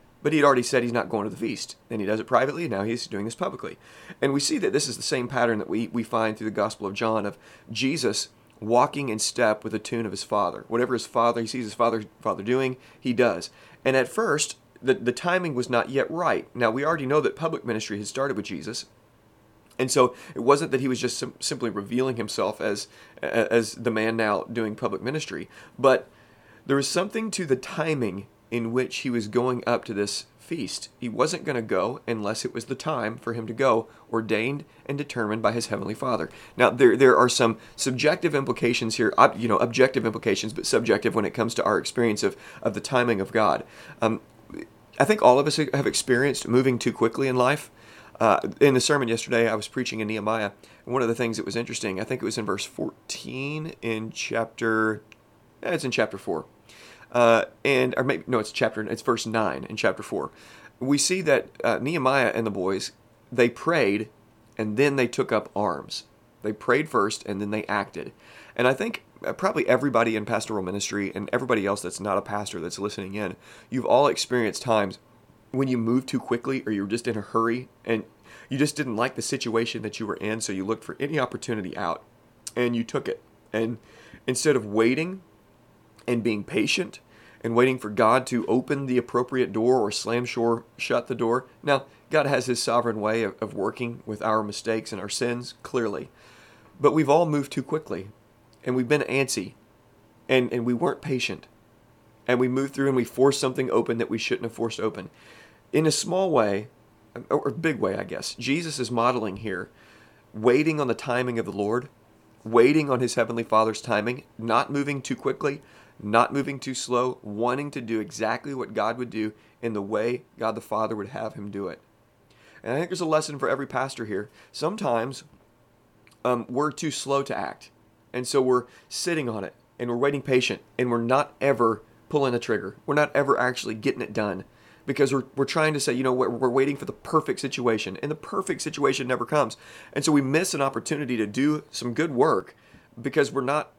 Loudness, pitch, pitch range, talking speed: -25 LUFS, 120 Hz, 110-135 Hz, 210 wpm